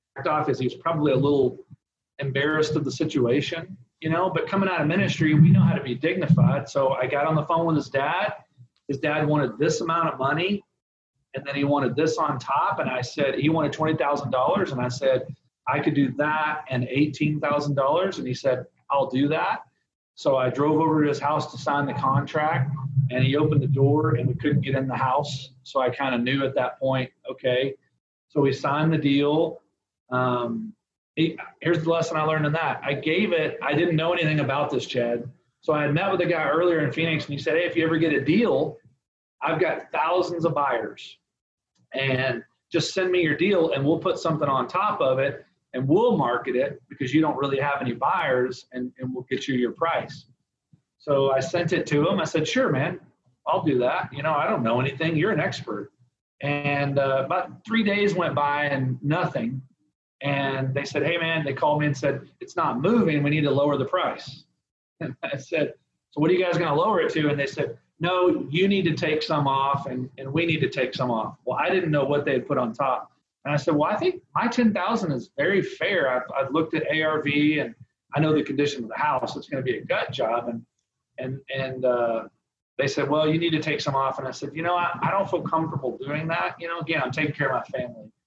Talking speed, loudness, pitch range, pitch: 230 wpm, -24 LUFS, 135-160 Hz, 145 Hz